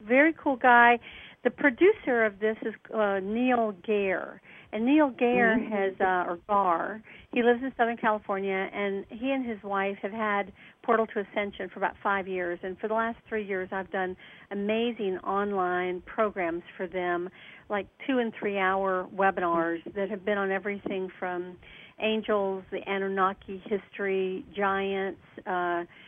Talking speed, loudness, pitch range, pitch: 155 wpm, -28 LUFS, 190-225 Hz, 200 Hz